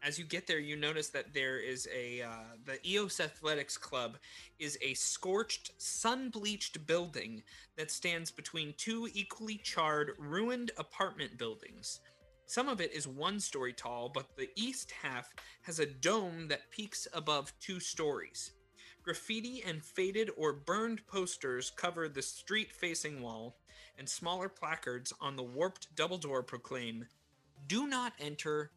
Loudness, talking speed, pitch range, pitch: -38 LUFS, 150 wpm, 135-195 Hz, 160 Hz